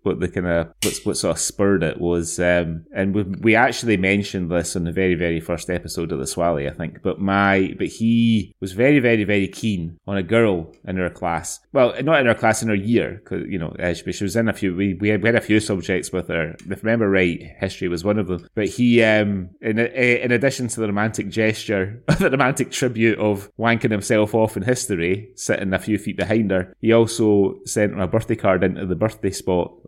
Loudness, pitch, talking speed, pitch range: -20 LUFS, 105 Hz, 230 wpm, 95-115 Hz